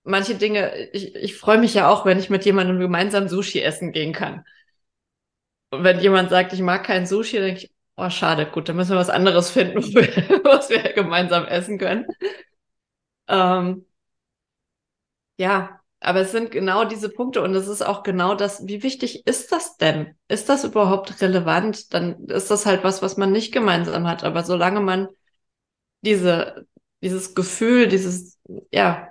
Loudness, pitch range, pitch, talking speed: -20 LUFS, 185-210 Hz, 195 Hz, 170 wpm